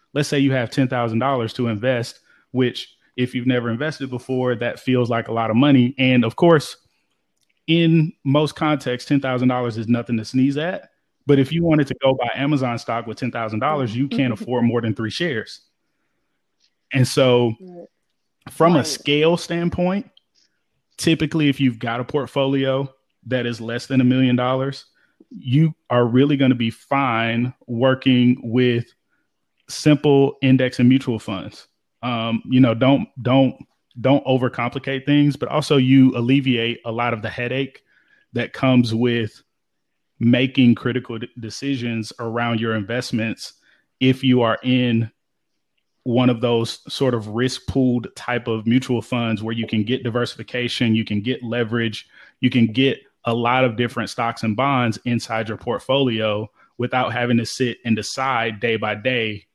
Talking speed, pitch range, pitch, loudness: 155 wpm, 115-135 Hz, 125 Hz, -20 LUFS